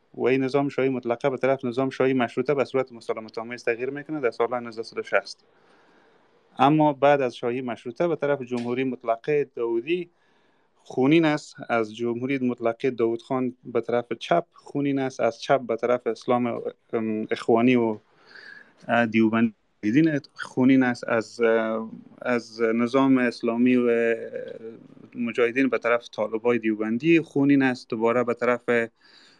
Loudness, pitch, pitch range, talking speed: -24 LUFS, 125 Hz, 115-135 Hz, 135 wpm